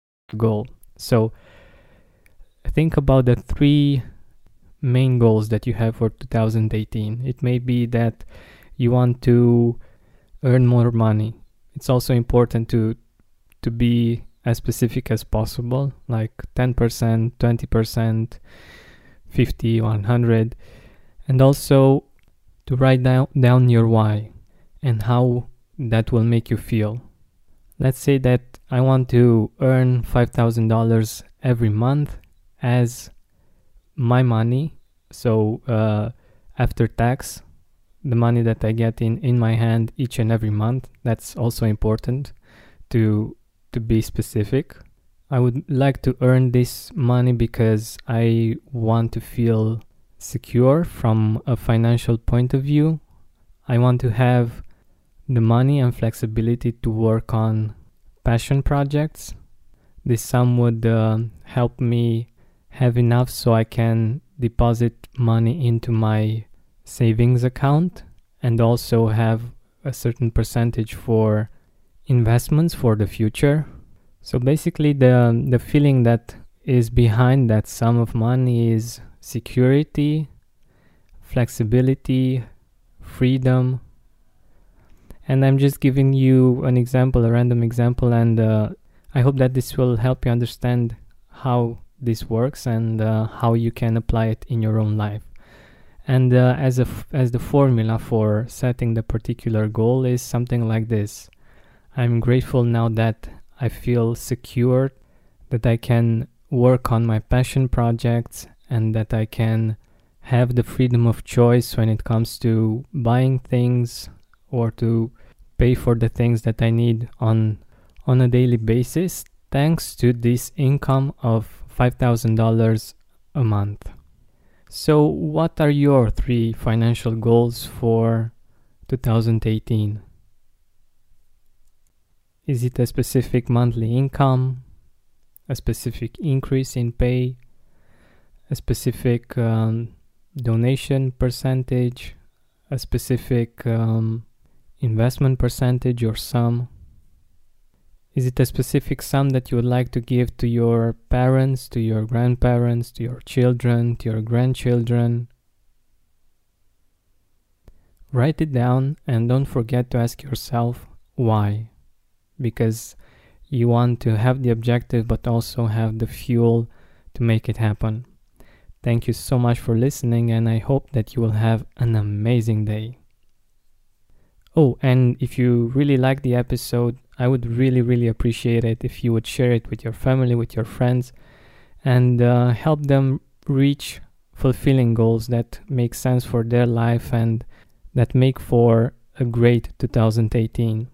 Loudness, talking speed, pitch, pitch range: -20 LUFS, 130 wpm, 120 Hz, 110-125 Hz